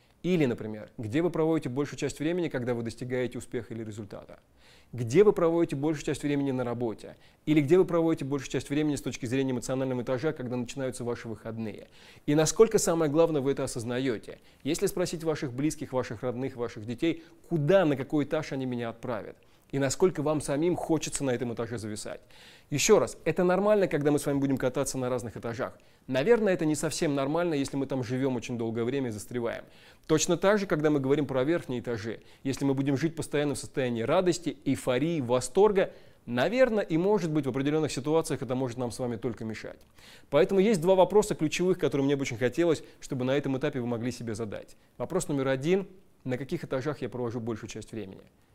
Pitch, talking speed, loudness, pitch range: 140 Hz, 195 wpm, -28 LUFS, 125-160 Hz